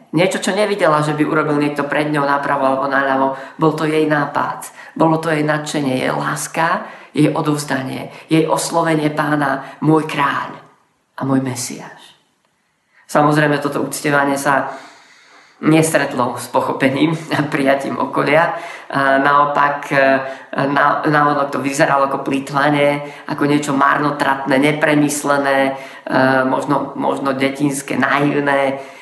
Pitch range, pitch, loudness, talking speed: 135-150 Hz, 145 Hz, -16 LUFS, 120 wpm